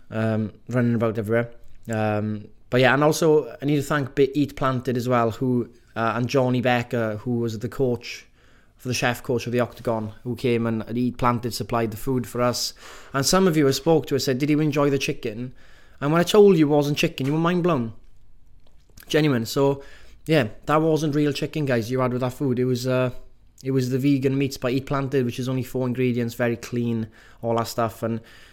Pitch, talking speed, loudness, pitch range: 125 Hz, 220 wpm, -23 LUFS, 115-140 Hz